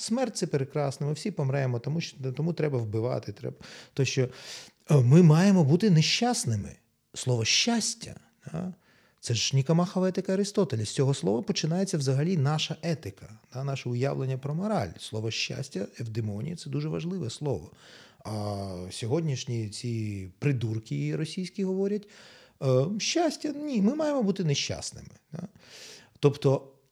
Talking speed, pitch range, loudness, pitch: 130 wpm, 125-185 Hz, -28 LUFS, 145 Hz